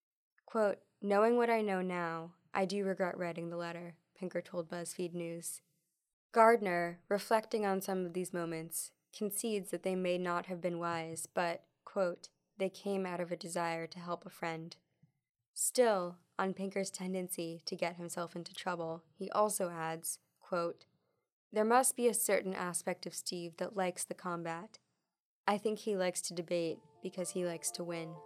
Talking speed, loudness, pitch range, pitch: 170 wpm, -36 LUFS, 170-195 Hz, 180 Hz